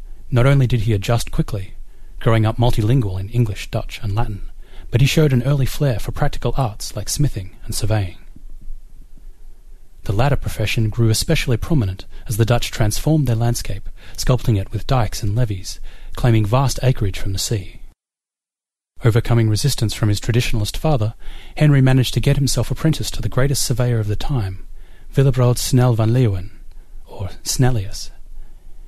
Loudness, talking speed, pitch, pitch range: -19 LUFS, 160 wpm, 115 Hz, 100-125 Hz